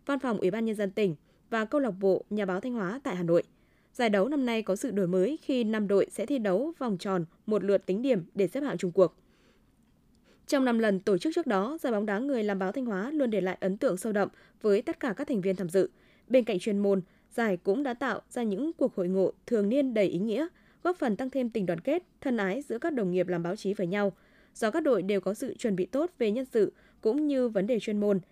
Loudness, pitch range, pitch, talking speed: -29 LUFS, 190-260 Hz, 215 Hz, 270 wpm